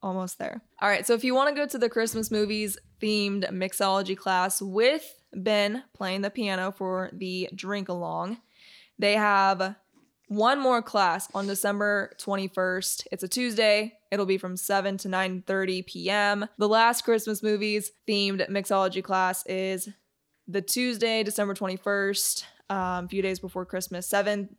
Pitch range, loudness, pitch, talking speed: 190-215 Hz, -27 LUFS, 200 Hz, 155 wpm